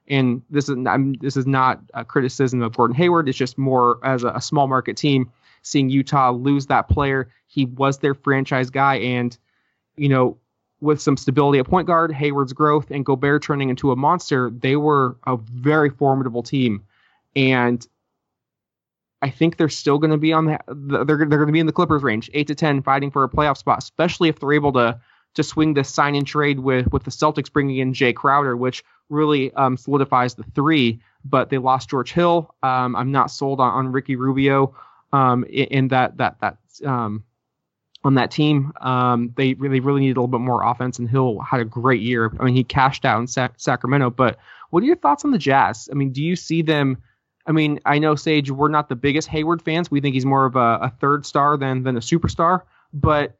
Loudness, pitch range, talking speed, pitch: -19 LUFS, 125-150 Hz, 215 wpm, 135 Hz